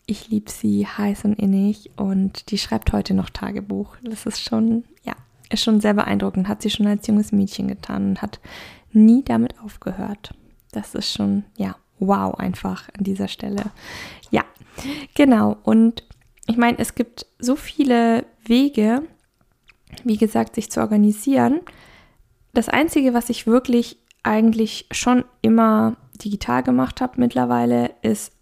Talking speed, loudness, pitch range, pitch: 145 wpm, -20 LUFS, 190-235 Hz, 215 Hz